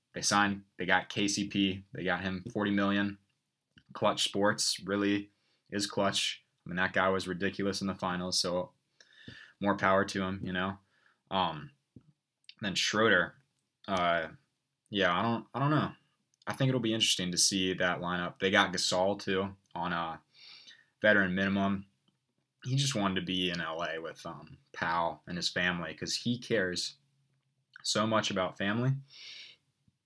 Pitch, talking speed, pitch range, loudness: 100 Hz, 155 wpm, 90-105 Hz, -31 LUFS